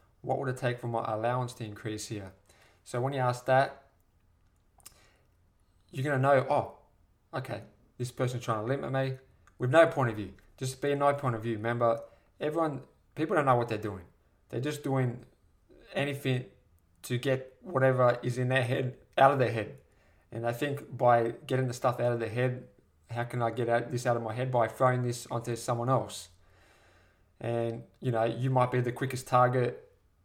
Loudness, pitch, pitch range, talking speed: -30 LUFS, 120 Hz, 110-130 Hz, 190 wpm